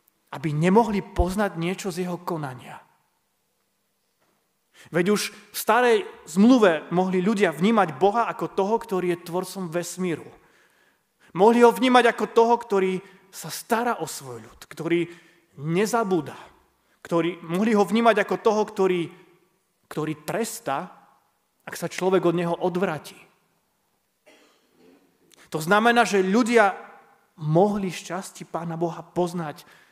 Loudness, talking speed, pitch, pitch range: -23 LUFS, 120 wpm, 185 Hz, 170-210 Hz